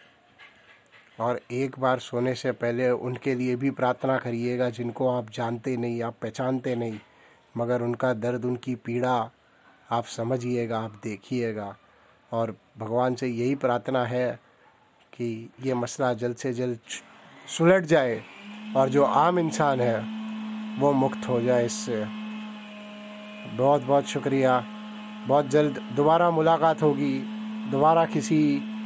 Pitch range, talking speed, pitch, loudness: 120-160 Hz, 125 wpm, 130 Hz, -26 LUFS